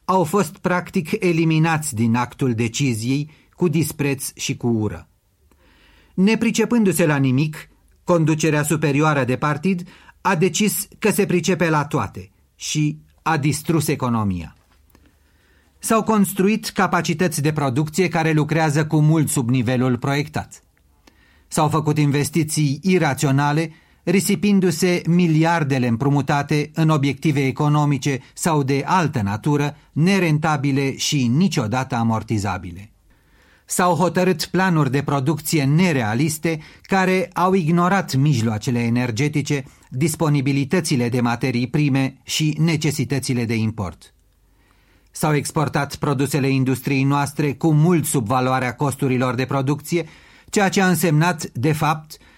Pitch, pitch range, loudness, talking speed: 150 Hz, 130-170 Hz, -20 LUFS, 110 wpm